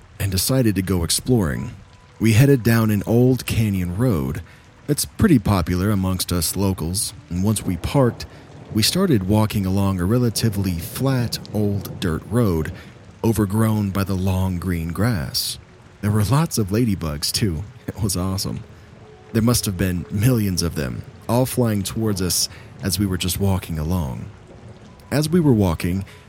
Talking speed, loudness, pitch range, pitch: 155 wpm, -20 LUFS, 95-115 Hz, 105 Hz